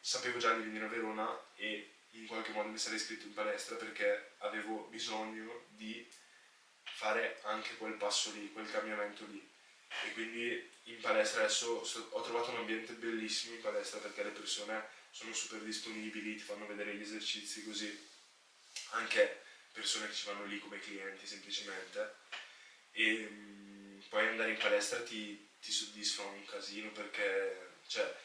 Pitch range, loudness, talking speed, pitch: 105-120 Hz, -39 LUFS, 155 wpm, 110 Hz